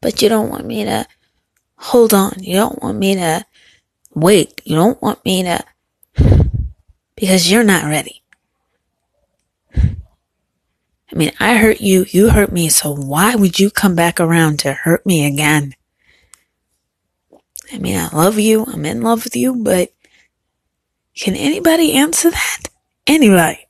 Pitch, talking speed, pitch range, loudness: 195 Hz, 145 wpm, 170-235 Hz, -14 LUFS